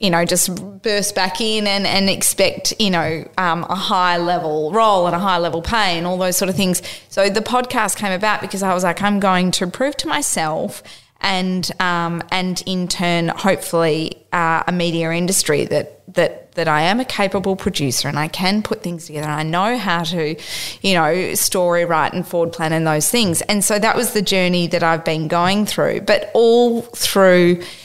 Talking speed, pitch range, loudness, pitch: 205 wpm, 170-200 Hz, -17 LUFS, 180 Hz